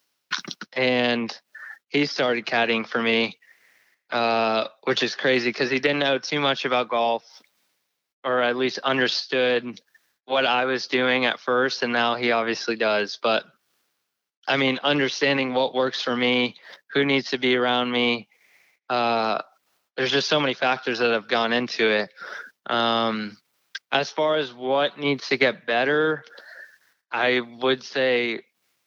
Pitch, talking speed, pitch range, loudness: 125 Hz, 145 wpm, 120-135 Hz, -23 LUFS